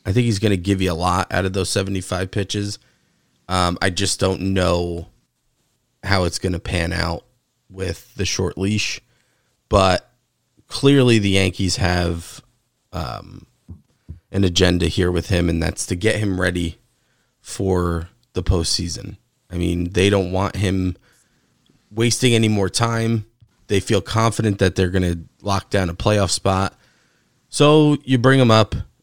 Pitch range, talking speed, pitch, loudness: 90-115 Hz, 155 wpm, 95 Hz, -19 LUFS